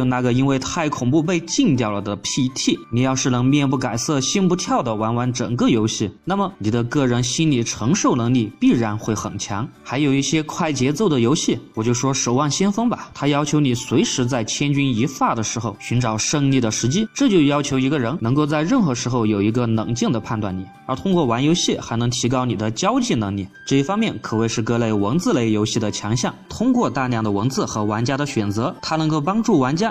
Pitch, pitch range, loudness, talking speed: 125 Hz, 115-150 Hz, -20 LUFS, 330 characters per minute